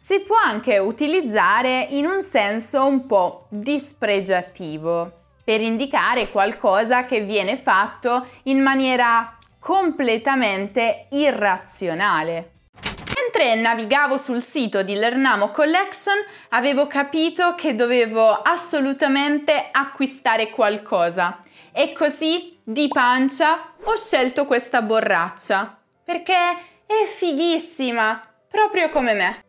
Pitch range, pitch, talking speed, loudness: 220-315 Hz, 270 Hz, 100 wpm, -20 LUFS